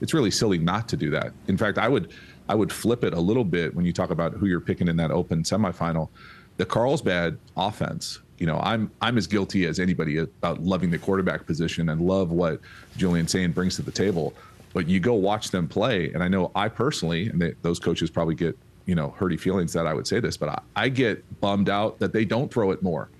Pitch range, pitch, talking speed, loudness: 85-95 Hz, 90 Hz, 240 wpm, -25 LUFS